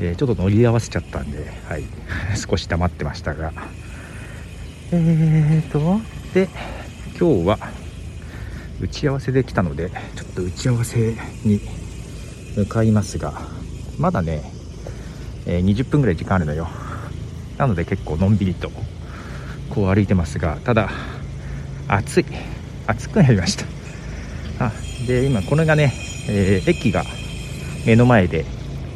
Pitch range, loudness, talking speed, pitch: 85-115 Hz, -21 LUFS, 245 characters per minute, 100 Hz